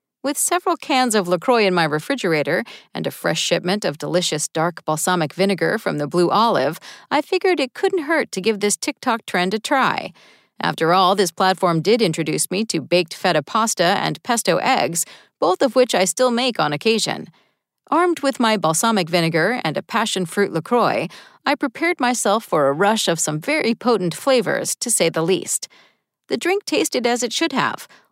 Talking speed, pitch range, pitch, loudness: 185 wpm, 175-255 Hz, 205 Hz, -19 LUFS